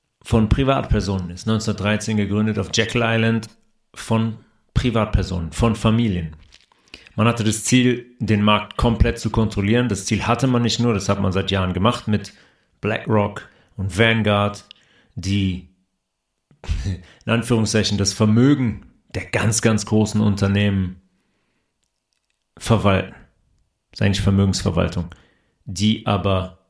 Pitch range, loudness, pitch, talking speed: 95-115 Hz, -20 LUFS, 105 Hz, 120 wpm